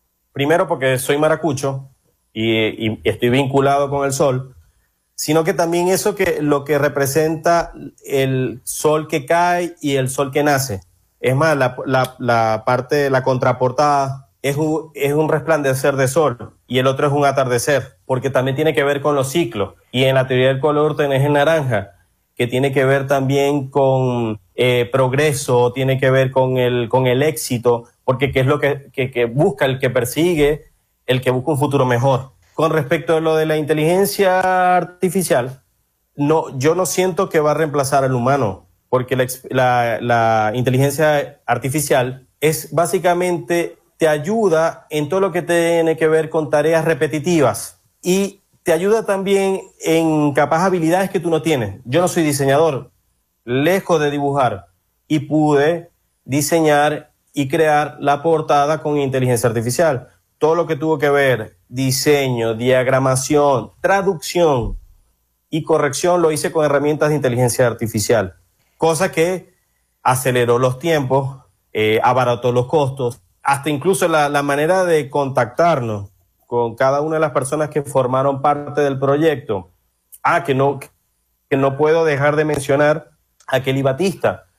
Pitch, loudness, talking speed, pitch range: 140 Hz, -17 LUFS, 155 wpm, 125-155 Hz